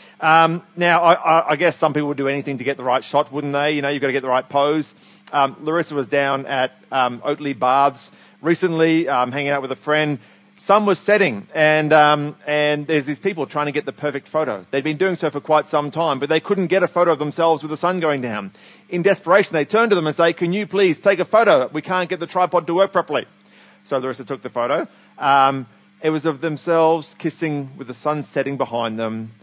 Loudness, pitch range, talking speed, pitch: -19 LUFS, 140-170 Hz, 240 wpm, 150 Hz